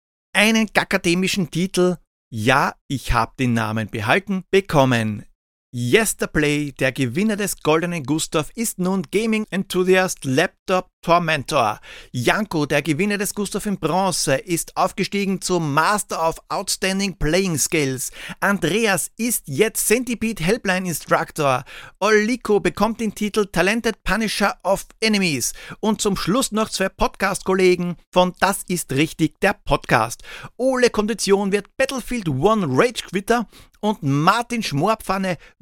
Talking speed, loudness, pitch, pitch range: 125 wpm, -20 LUFS, 185 Hz, 155-210 Hz